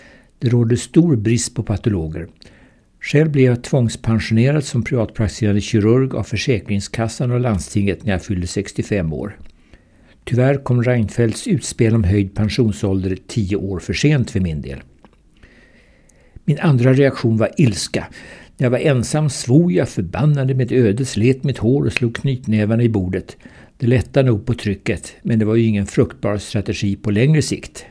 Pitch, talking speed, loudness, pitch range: 115 Hz, 155 wpm, -18 LUFS, 100-130 Hz